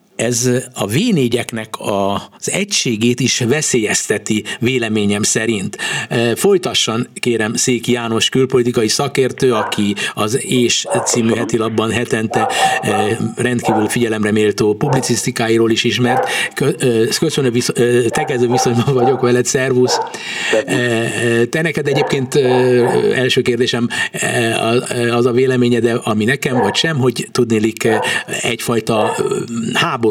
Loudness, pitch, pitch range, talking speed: -15 LUFS, 120 Hz, 115-125 Hz, 100 wpm